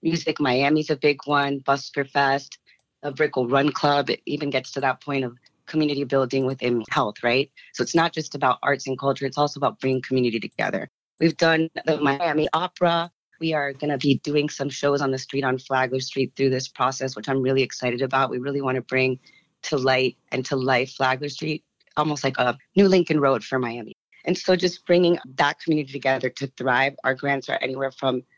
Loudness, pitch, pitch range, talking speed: -23 LUFS, 140 Hz, 130-150 Hz, 205 wpm